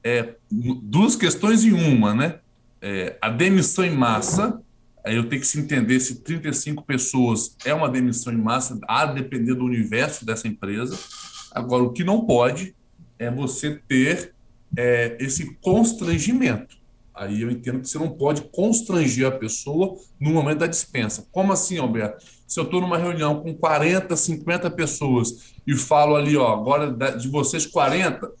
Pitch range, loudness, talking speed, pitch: 120-170 Hz, -21 LUFS, 160 wpm, 140 Hz